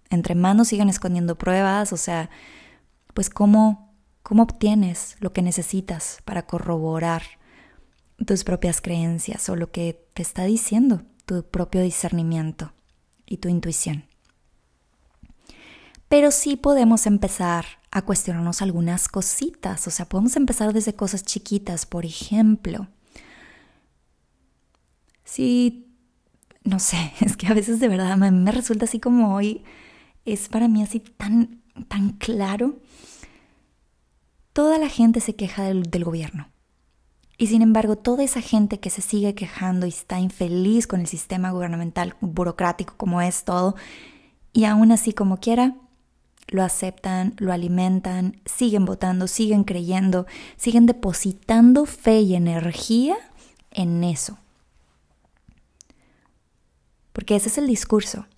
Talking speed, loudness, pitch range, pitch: 130 wpm, -21 LUFS, 175-220 Hz, 195 Hz